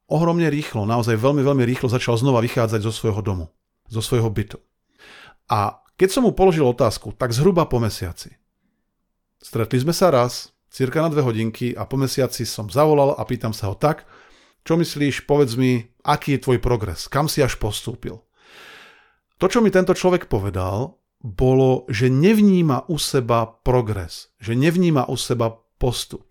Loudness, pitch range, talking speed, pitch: -20 LUFS, 115-150 Hz, 165 wpm, 130 Hz